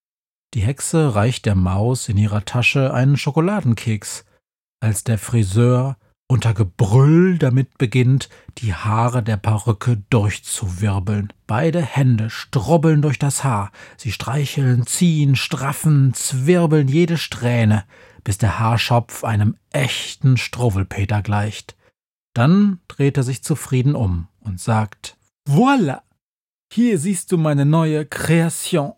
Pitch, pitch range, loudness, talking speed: 125 Hz, 110-145 Hz, -18 LUFS, 120 wpm